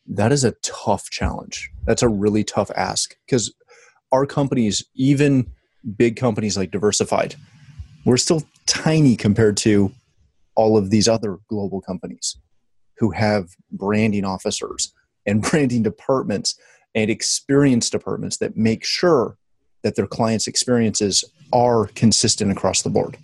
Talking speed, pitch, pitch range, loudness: 130 wpm, 110 Hz, 100-125 Hz, -20 LUFS